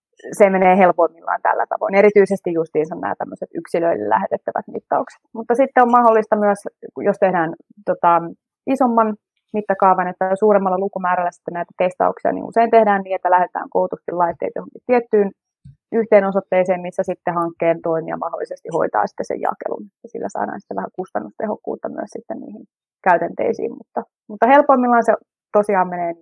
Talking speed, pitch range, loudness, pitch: 145 wpm, 180-230 Hz, -18 LUFS, 195 Hz